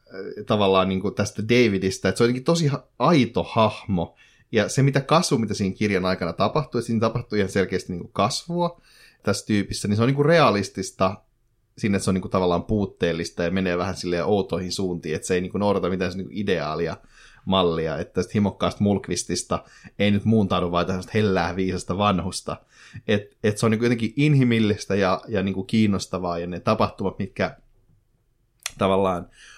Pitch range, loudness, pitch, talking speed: 95-115 Hz, -23 LUFS, 100 Hz, 175 wpm